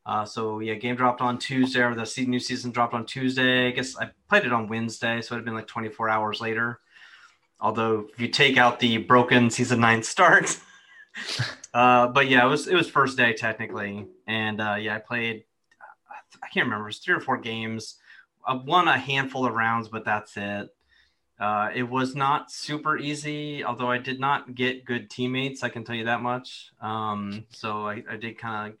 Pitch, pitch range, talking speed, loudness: 120 Hz, 110-125 Hz, 205 wpm, -24 LUFS